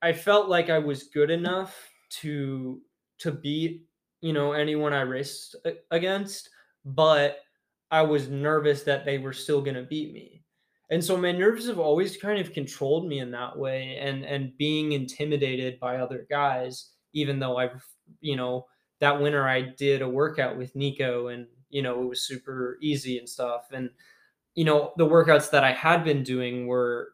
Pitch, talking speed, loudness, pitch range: 145 Hz, 175 wpm, -26 LUFS, 130-160 Hz